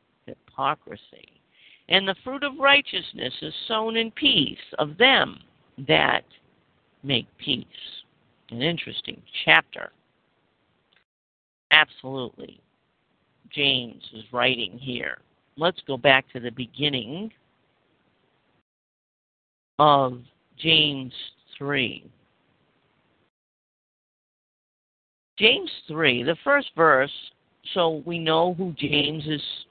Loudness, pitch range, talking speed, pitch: -22 LUFS, 125-175 Hz, 85 wpm, 145 Hz